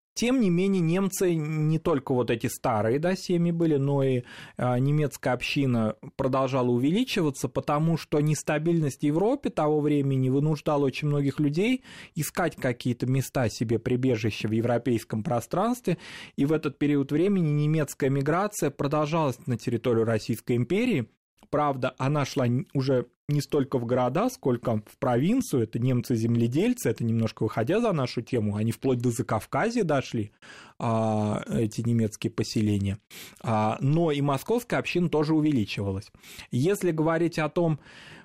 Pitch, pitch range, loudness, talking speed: 140 Hz, 120-155 Hz, -26 LUFS, 135 wpm